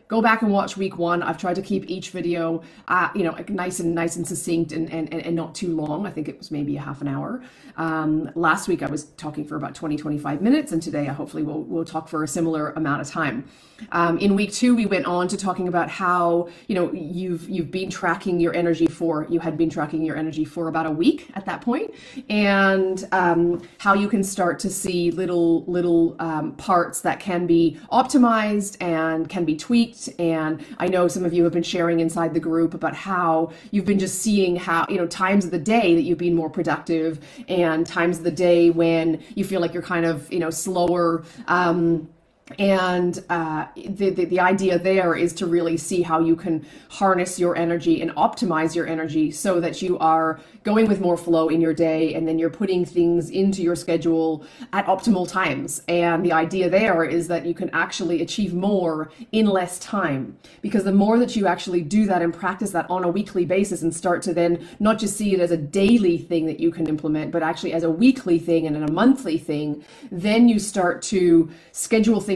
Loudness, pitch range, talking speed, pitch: -22 LUFS, 165-190 Hz, 215 wpm, 170 Hz